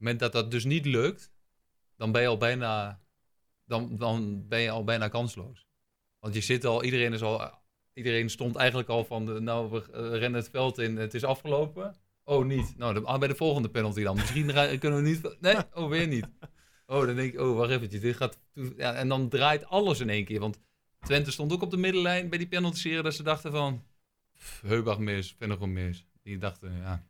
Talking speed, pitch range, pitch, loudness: 215 wpm, 110-140 Hz, 120 Hz, -29 LUFS